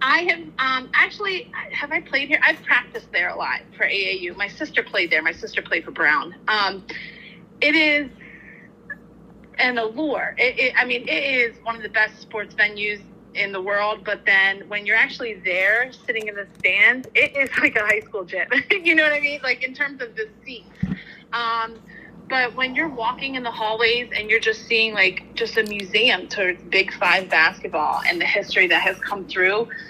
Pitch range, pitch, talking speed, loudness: 205-260 Hz, 225 Hz, 200 wpm, -20 LUFS